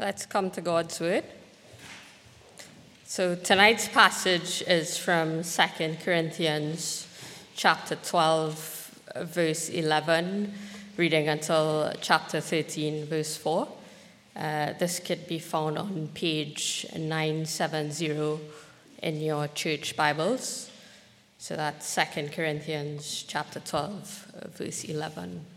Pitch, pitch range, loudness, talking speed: 160 Hz, 155-180 Hz, -28 LUFS, 100 wpm